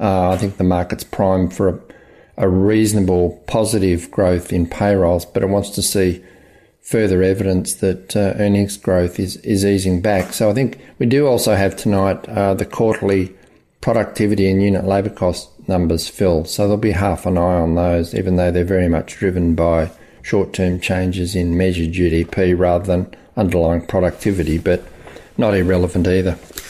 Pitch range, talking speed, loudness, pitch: 90-100 Hz, 170 wpm, -17 LUFS, 95 Hz